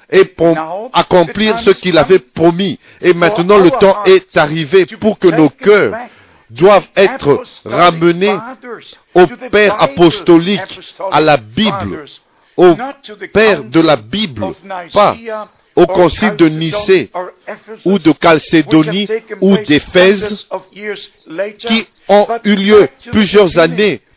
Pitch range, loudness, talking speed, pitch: 170-210 Hz, -10 LUFS, 115 wpm, 190 Hz